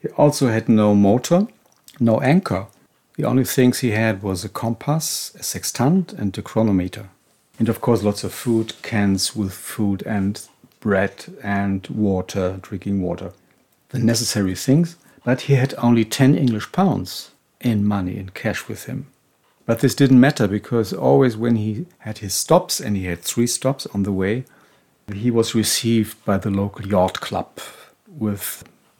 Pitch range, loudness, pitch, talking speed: 100-125 Hz, -20 LUFS, 110 Hz, 165 wpm